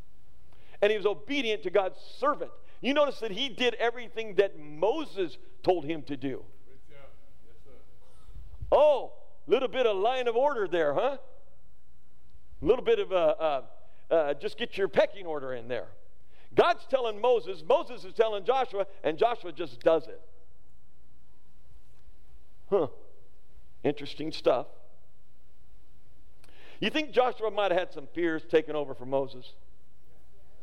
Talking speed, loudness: 135 wpm, -29 LUFS